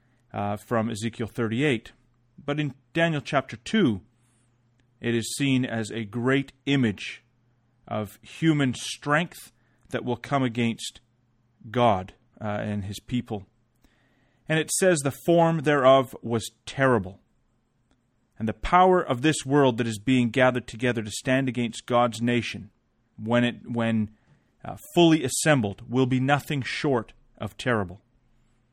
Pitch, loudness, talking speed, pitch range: 120 Hz, -25 LUFS, 135 wpm, 115-130 Hz